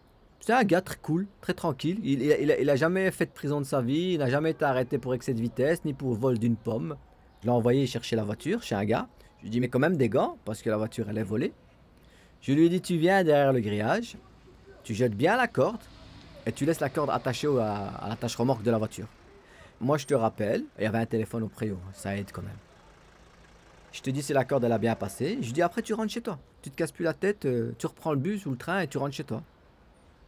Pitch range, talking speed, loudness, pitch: 115-160 Hz, 270 wpm, -28 LUFS, 130 Hz